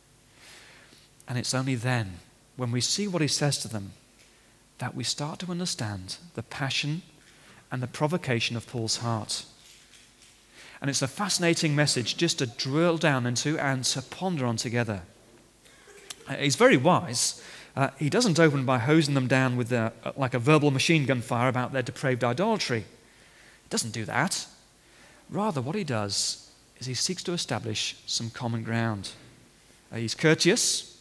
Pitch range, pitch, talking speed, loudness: 115-145 Hz, 130 Hz, 160 wpm, -26 LUFS